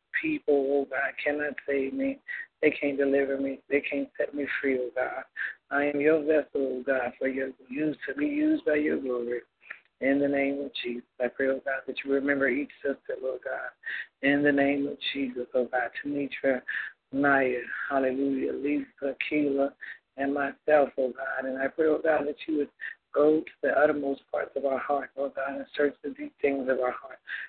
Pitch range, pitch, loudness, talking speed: 135-150 Hz, 140 Hz, -28 LUFS, 195 wpm